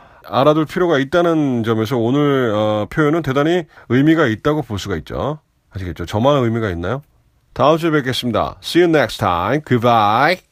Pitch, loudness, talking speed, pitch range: 130 Hz, -16 LUFS, 420 characters per minute, 110-150 Hz